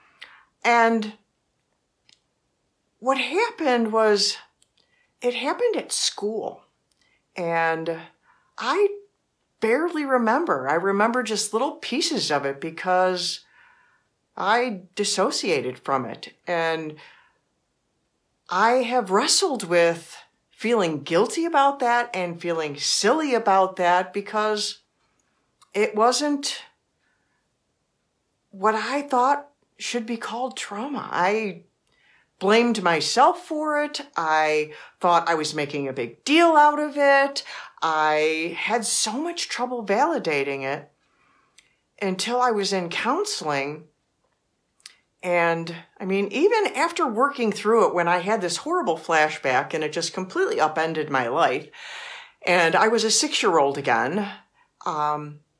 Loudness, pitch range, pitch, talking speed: -22 LUFS, 170-275 Hz, 215 Hz, 115 wpm